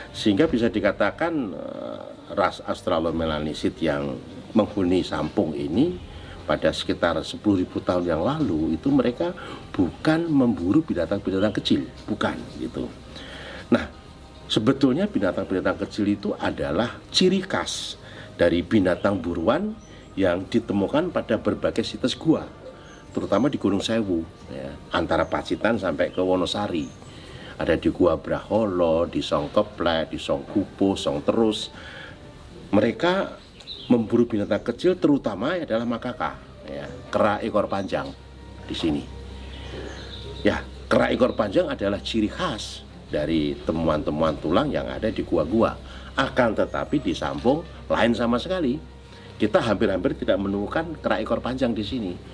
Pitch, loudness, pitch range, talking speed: 100 Hz, -24 LUFS, 80-120 Hz, 120 wpm